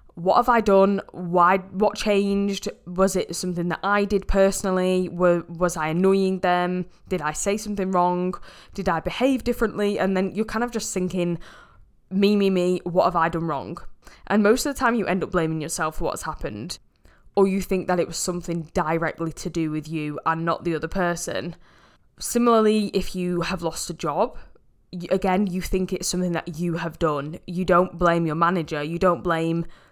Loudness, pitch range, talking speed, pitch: -23 LUFS, 170-195 Hz, 195 wpm, 180 Hz